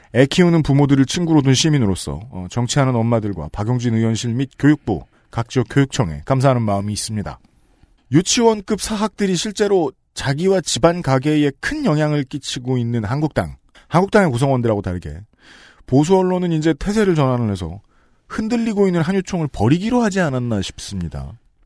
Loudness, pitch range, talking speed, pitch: -18 LUFS, 115-175 Hz, 375 characters per minute, 135 Hz